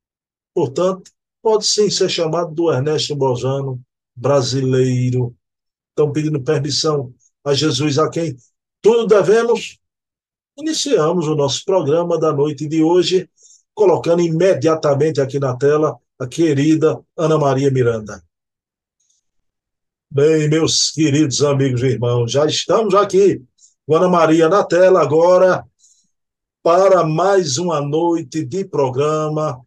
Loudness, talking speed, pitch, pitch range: -16 LUFS, 115 wpm, 155 Hz, 140-175 Hz